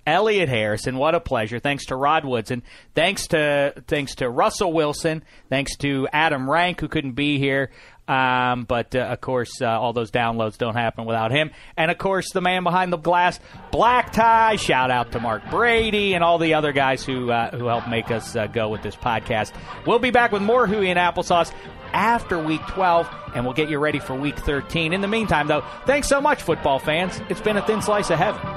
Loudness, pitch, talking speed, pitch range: -21 LUFS, 145 Hz, 215 wpm, 125-180 Hz